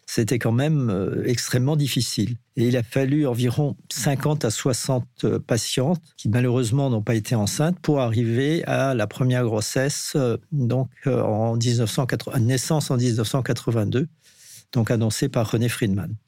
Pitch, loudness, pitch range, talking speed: 125 Hz, -23 LUFS, 115-140 Hz, 135 wpm